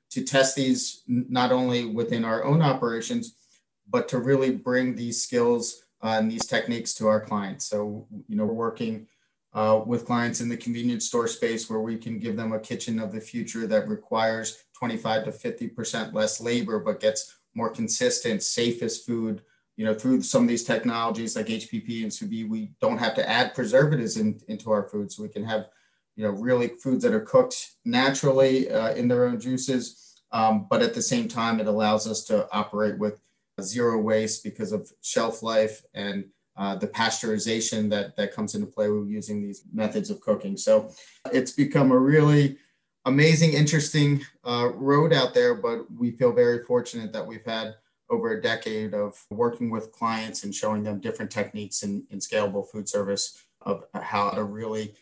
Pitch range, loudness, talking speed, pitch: 110-140 Hz, -26 LUFS, 185 wpm, 115 Hz